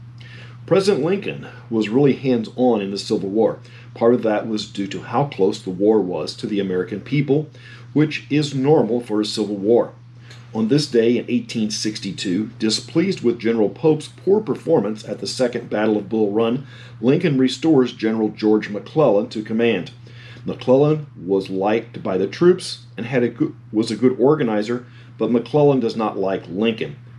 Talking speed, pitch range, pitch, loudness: 170 wpm, 110-130 Hz, 120 Hz, -20 LUFS